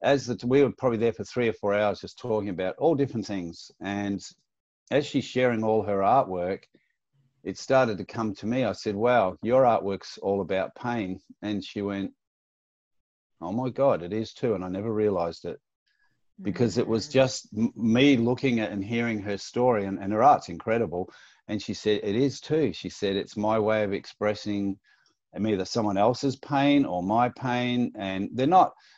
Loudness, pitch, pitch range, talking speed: -26 LUFS, 110 Hz, 100-125 Hz, 190 wpm